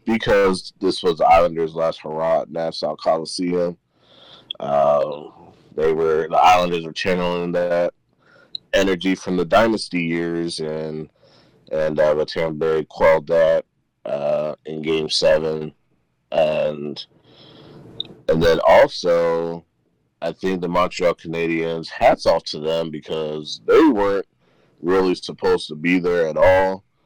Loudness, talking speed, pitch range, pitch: -19 LUFS, 125 wpm, 80-95 Hz, 85 Hz